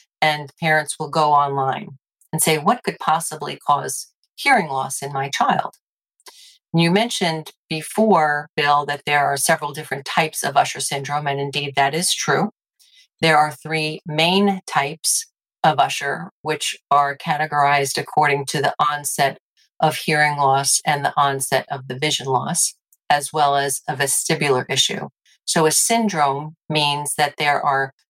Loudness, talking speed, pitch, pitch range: -19 LUFS, 150 wpm, 150 Hz, 140-160 Hz